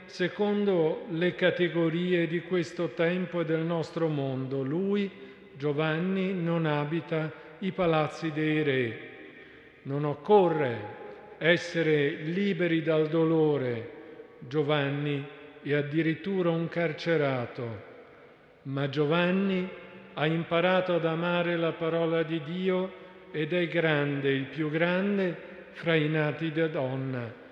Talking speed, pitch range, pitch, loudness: 110 wpm, 150-175 Hz, 165 Hz, -28 LUFS